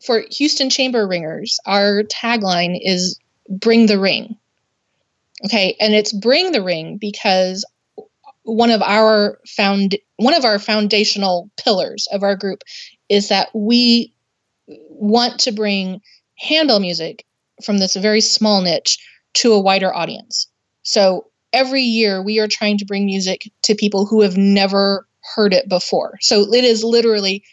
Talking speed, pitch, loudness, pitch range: 145 wpm, 210 Hz, -15 LUFS, 195-230 Hz